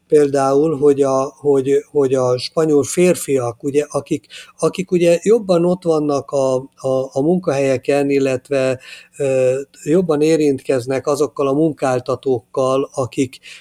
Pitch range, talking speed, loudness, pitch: 135-155 Hz, 120 wpm, -17 LUFS, 140 Hz